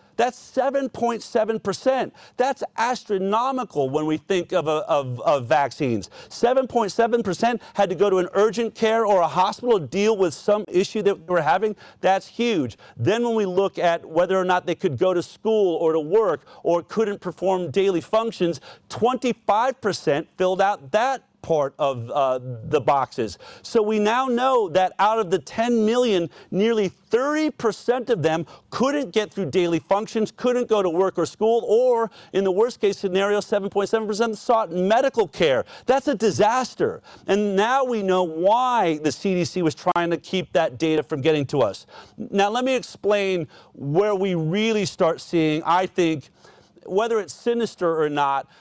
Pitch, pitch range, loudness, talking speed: 200 Hz, 175-230 Hz, -22 LUFS, 170 wpm